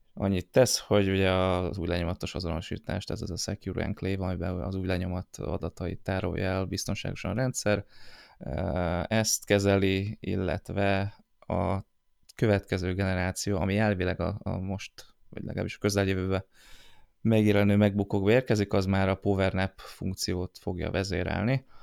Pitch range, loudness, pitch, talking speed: 90-100 Hz, -29 LUFS, 95 Hz, 130 wpm